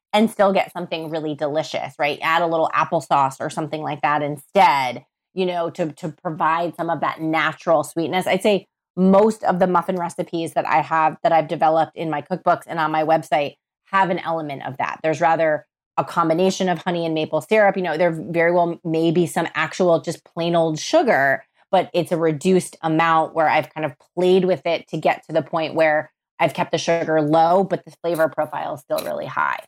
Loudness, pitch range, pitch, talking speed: -20 LUFS, 160-180 Hz, 165 Hz, 210 wpm